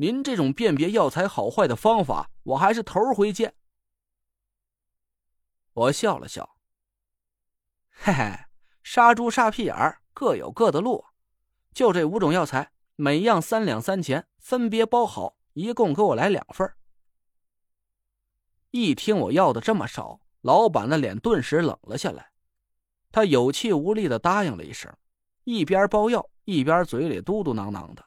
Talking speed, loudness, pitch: 215 characters per minute, -23 LUFS, 165 Hz